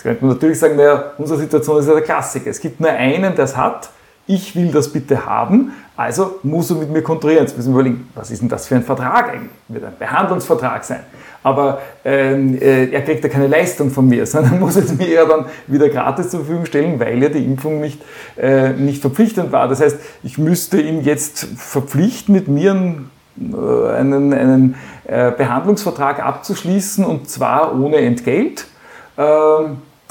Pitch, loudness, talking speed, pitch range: 150 Hz, -15 LUFS, 195 wpm, 135-165 Hz